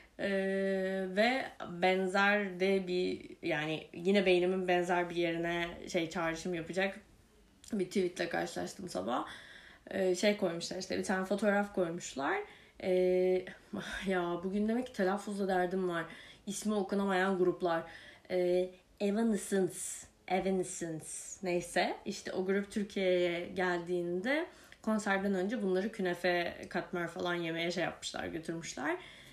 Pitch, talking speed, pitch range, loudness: 185 Hz, 115 wpm, 175-200 Hz, -34 LUFS